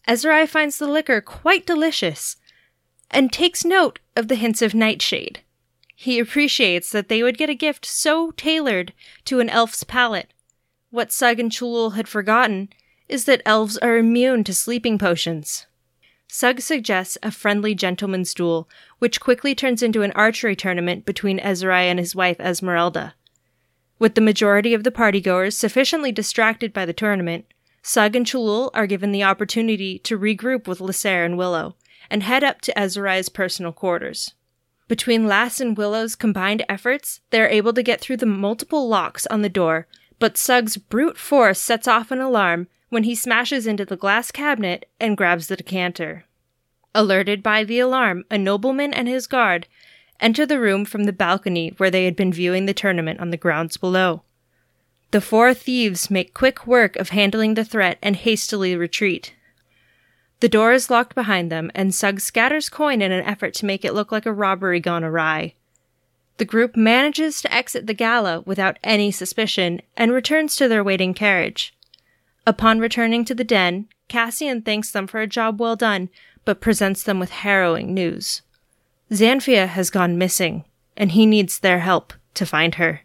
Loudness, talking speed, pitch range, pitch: -19 LUFS, 170 wpm, 185-240 Hz, 215 Hz